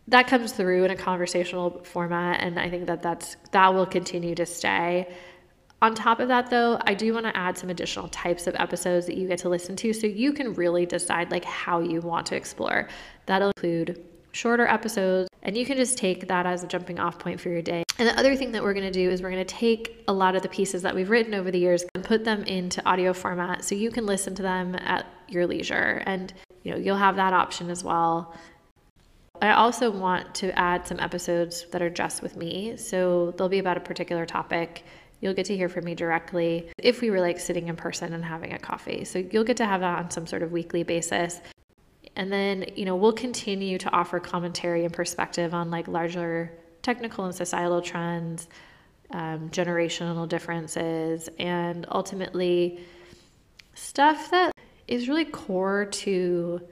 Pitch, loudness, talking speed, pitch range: 180 Hz, -26 LUFS, 205 wpm, 175-195 Hz